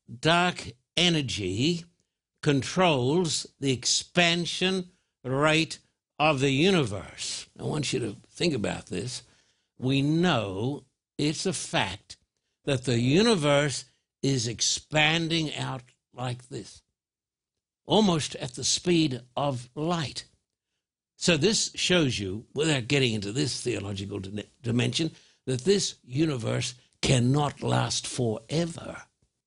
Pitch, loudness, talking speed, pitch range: 140 Hz, -26 LUFS, 105 wpm, 120-165 Hz